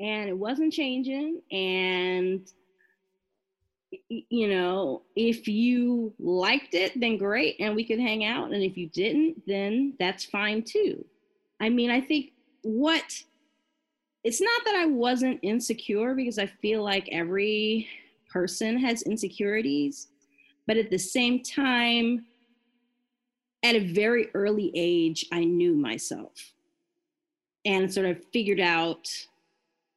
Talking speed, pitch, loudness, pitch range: 125 wpm, 230 Hz, -27 LUFS, 190-275 Hz